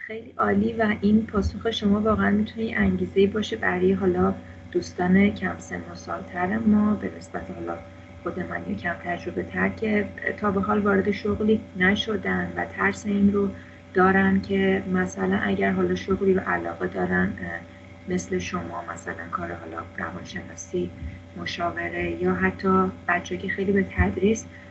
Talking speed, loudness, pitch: 150 wpm, -25 LUFS, 185 Hz